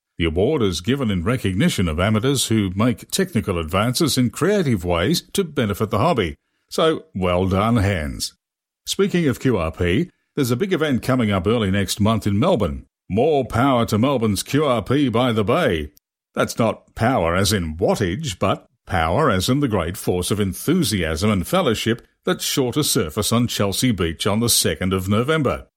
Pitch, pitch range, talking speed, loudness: 110 Hz, 95-130 Hz, 170 wpm, -20 LUFS